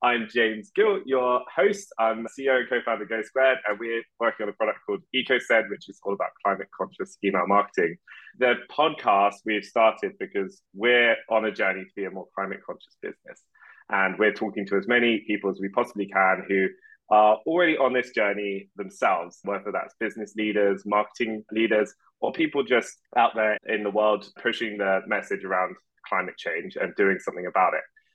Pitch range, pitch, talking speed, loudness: 100-120 Hz, 110 Hz, 190 wpm, -25 LUFS